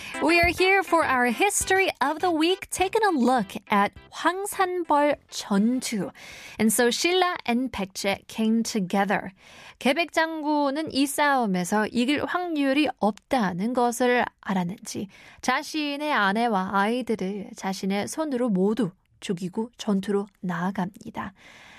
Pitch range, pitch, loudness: 205-305 Hz, 245 Hz, -24 LUFS